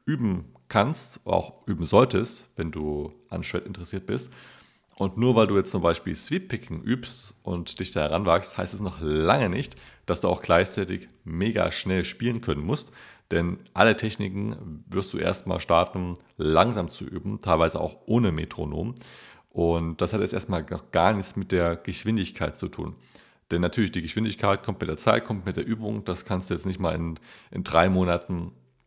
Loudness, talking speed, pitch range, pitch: -26 LUFS, 180 wpm, 85-105 Hz, 90 Hz